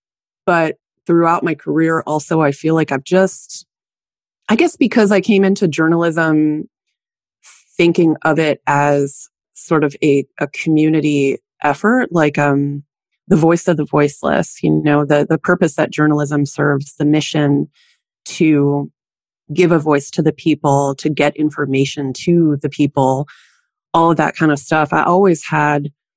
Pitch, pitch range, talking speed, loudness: 155 Hz, 145-170 Hz, 150 wpm, -15 LUFS